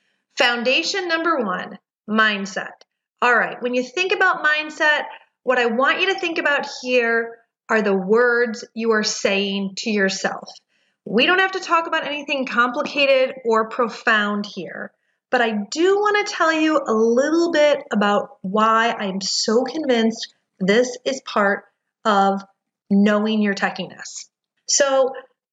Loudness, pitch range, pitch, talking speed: -19 LUFS, 215-290 Hz, 245 Hz, 145 wpm